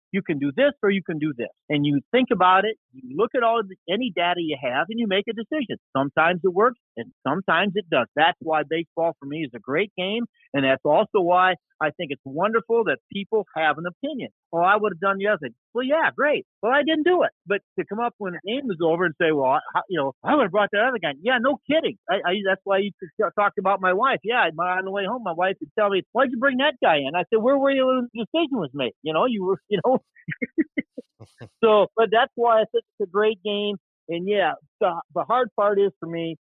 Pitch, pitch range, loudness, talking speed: 200 Hz, 175-235 Hz, -23 LUFS, 260 wpm